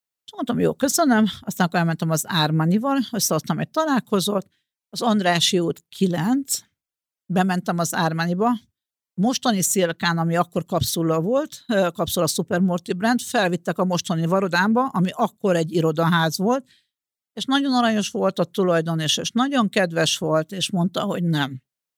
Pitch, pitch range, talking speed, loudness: 185 Hz, 170-225 Hz, 145 wpm, -21 LUFS